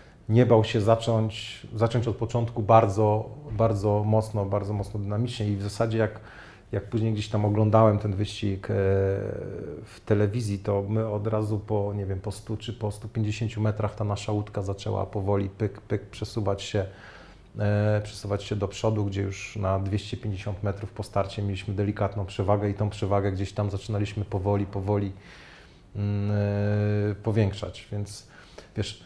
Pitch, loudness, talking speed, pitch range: 105 Hz, -27 LUFS, 150 wpm, 100-110 Hz